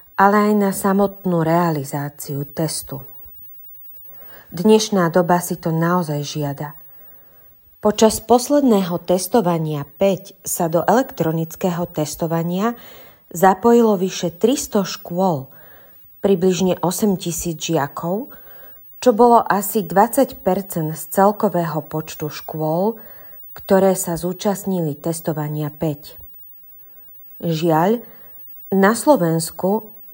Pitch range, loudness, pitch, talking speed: 155-200 Hz, -18 LUFS, 180 Hz, 85 wpm